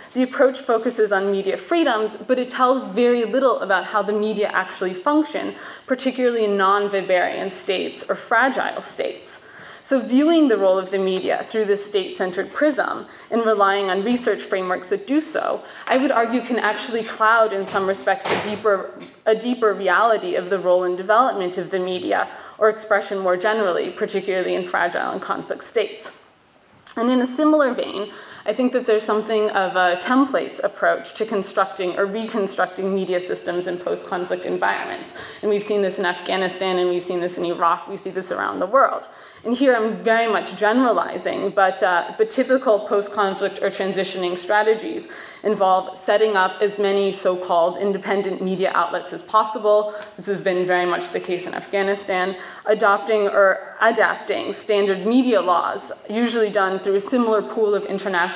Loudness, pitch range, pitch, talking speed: -20 LUFS, 190-225 Hz, 200 Hz, 170 wpm